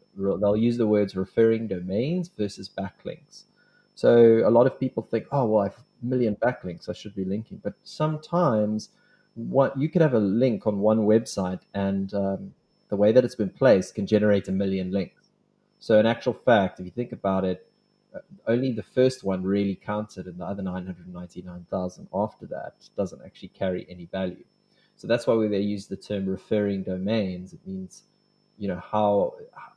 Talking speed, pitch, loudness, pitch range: 185 wpm, 105 Hz, -25 LUFS, 95-120 Hz